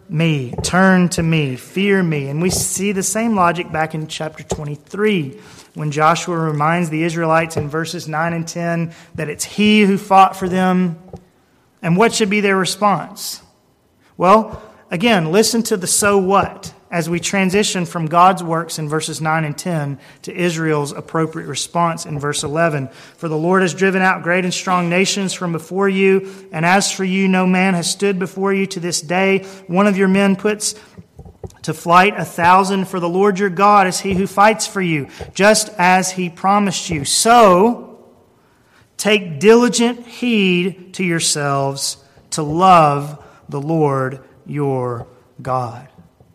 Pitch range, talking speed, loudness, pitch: 155-195 Hz, 165 wpm, -16 LUFS, 175 Hz